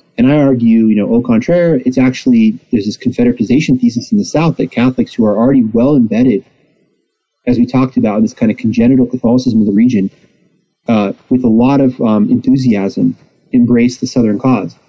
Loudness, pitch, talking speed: -11 LUFS, 135 Hz, 190 wpm